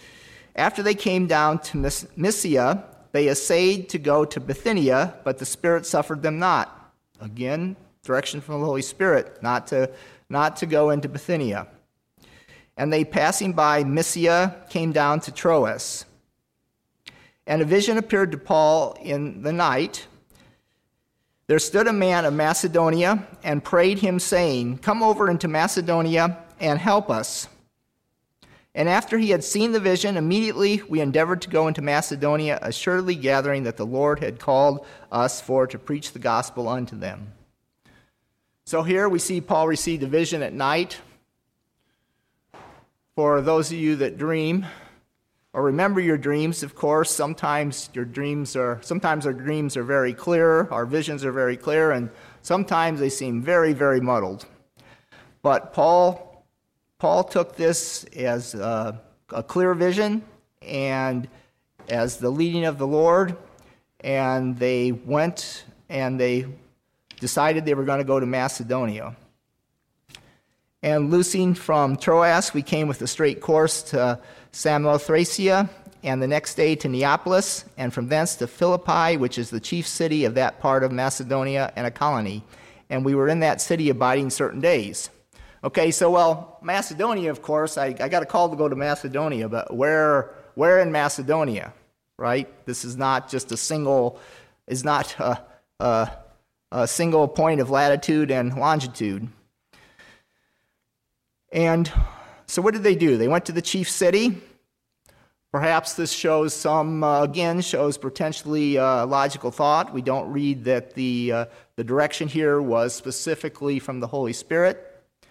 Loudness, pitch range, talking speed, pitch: -22 LUFS, 130-170 Hz, 150 wpm, 150 Hz